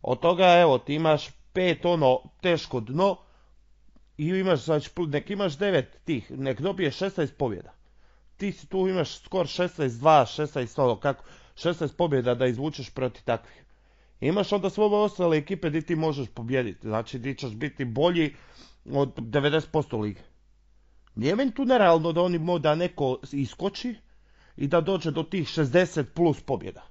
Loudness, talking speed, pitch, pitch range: -26 LUFS, 160 wpm, 155 Hz, 135-175 Hz